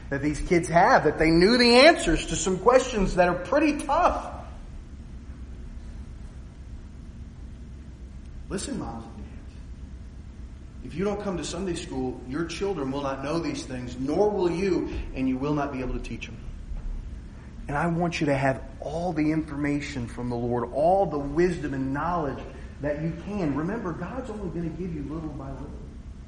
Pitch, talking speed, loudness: 140 Hz, 175 wpm, -25 LUFS